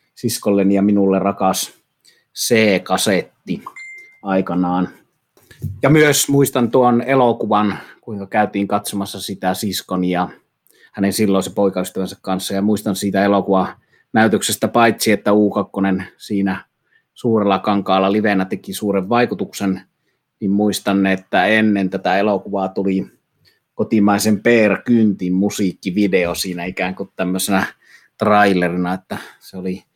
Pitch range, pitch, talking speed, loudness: 95-105 Hz, 100 Hz, 110 wpm, -17 LUFS